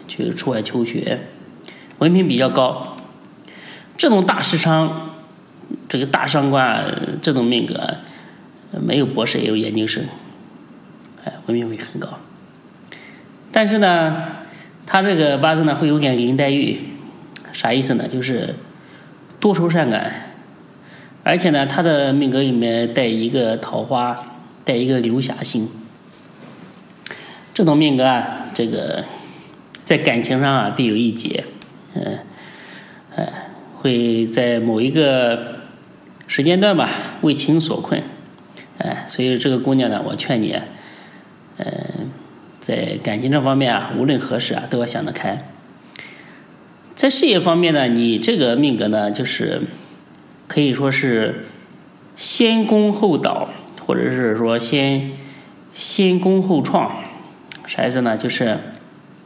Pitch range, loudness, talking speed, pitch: 120-160 Hz, -18 LUFS, 185 characters per minute, 135 Hz